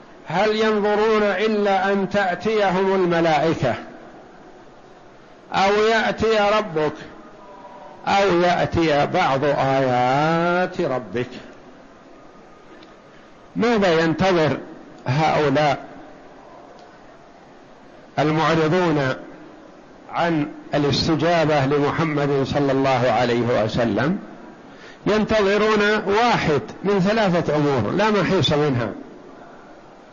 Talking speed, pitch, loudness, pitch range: 65 wpm, 170 Hz, -20 LUFS, 145-200 Hz